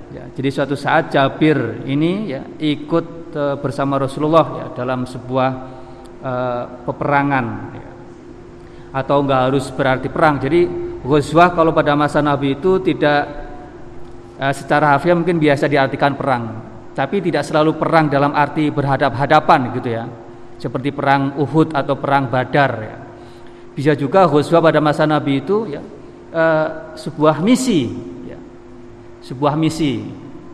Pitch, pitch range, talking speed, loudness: 140 Hz, 130-155 Hz, 130 wpm, -17 LUFS